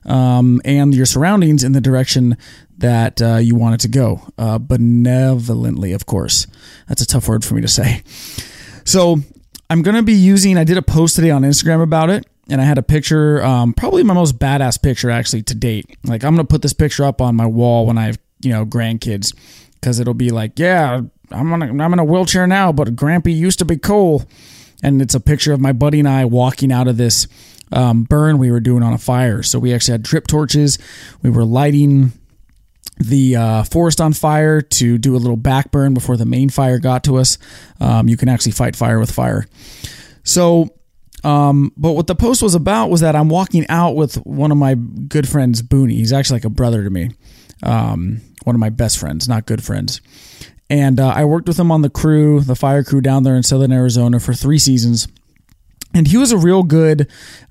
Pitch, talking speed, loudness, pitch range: 130 Hz, 215 wpm, -14 LUFS, 120-150 Hz